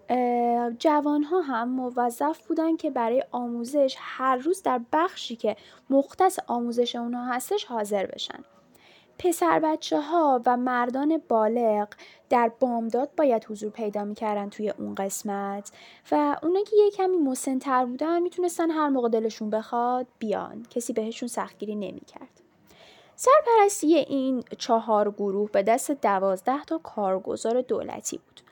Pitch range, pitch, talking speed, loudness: 225-300 Hz, 245 Hz, 130 wpm, -26 LUFS